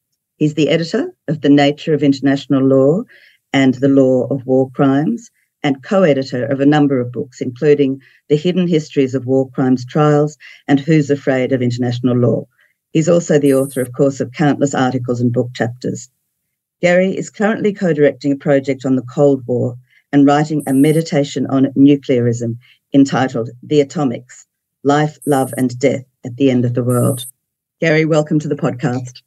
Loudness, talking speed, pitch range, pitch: -15 LUFS, 170 wpm, 130-150 Hz, 140 Hz